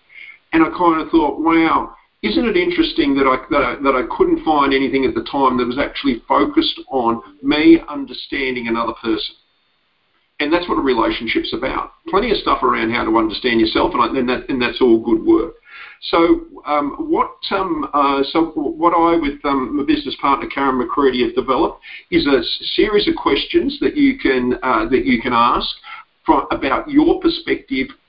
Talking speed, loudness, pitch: 185 wpm, -17 LUFS, 320 Hz